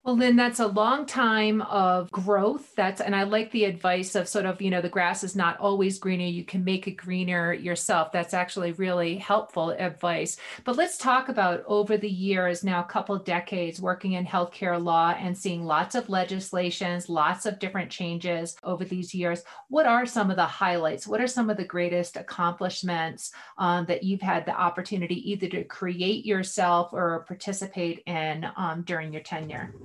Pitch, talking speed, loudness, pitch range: 185 Hz, 190 wpm, -27 LUFS, 175-205 Hz